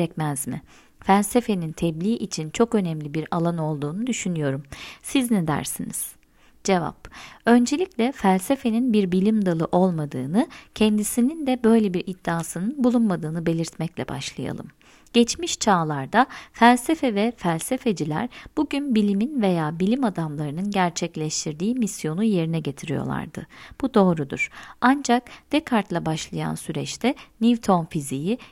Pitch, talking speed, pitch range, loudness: 200 Hz, 105 wpm, 165-235 Hz, -23 LUFS